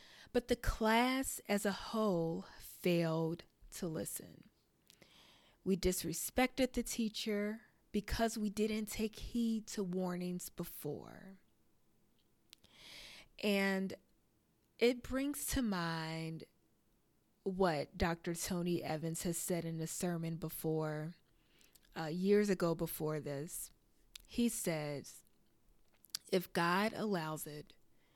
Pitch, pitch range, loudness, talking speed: 185 Hz, 165-215 Hz, -38 LUFS, 100 wpm